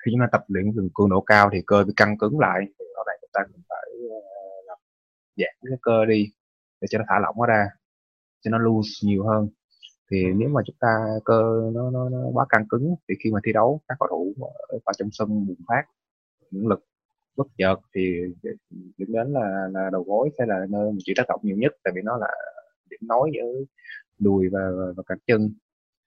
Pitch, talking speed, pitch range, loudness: 105 Hz, 220 wpm, 95-120 Hz, -23 LUFS